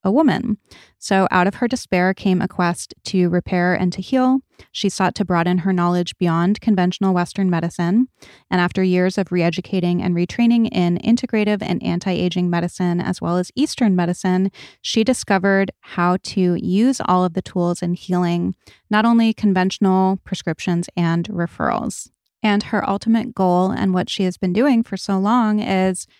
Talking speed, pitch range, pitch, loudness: 165 wpm, 180-205 Hz, 185 Hz, -19 LUFS